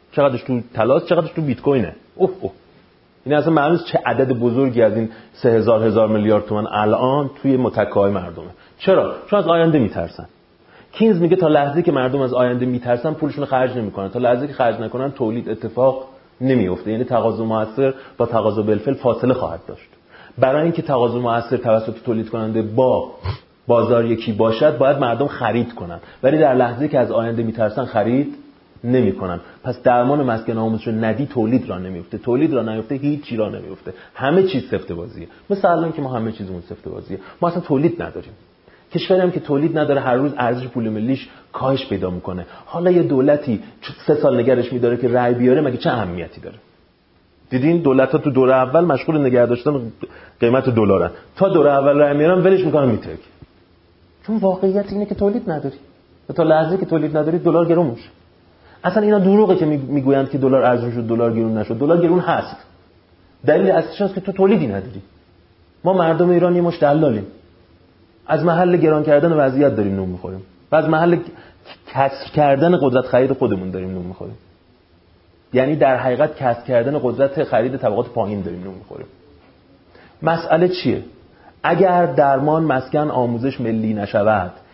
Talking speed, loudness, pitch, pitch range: 170 wpm, -18 LUFS, 125 Hz, 110-150 Hz